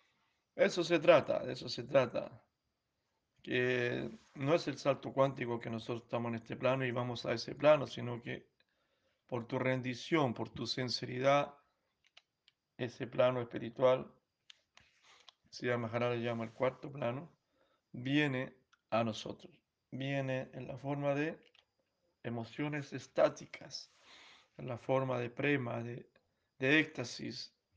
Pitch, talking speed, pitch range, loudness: 130 Hz, 125 wpm, 120-140 Hz, -35 LUFS